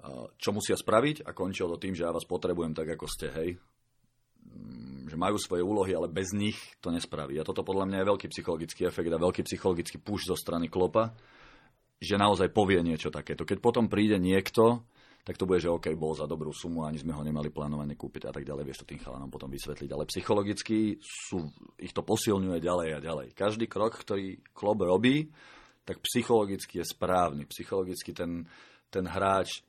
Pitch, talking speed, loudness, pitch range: 90 Hz, 190 wpm, -31 LUFS, 80-105 Hz